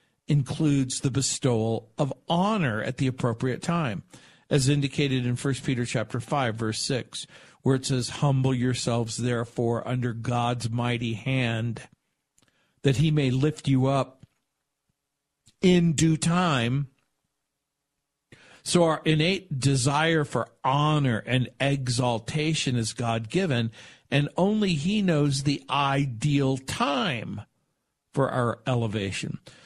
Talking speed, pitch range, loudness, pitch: 115 wpm, 120-145 Hz, -26 LUFS, 135 Hz